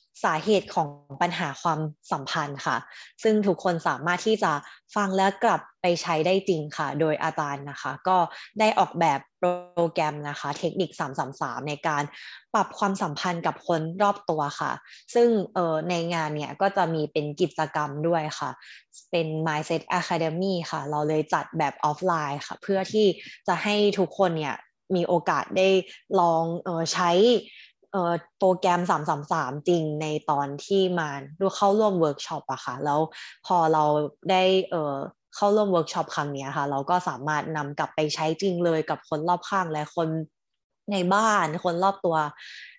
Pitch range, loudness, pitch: 150-185 Hz, -26 LUFS, 170 Hz